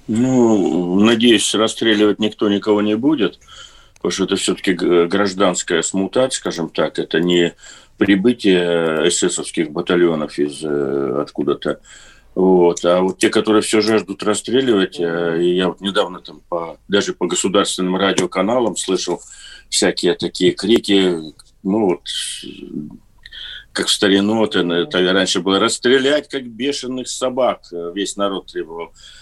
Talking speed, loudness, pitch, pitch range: 115 wpm, -17 LUFS, 95 Hz, 85-110 Hz